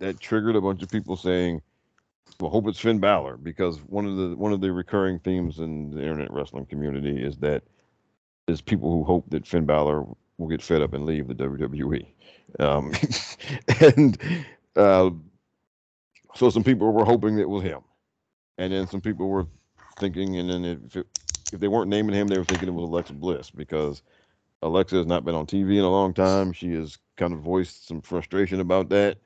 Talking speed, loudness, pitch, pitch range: 195 wpm, -24 LUFS, 90 Hz, 80-100 Hz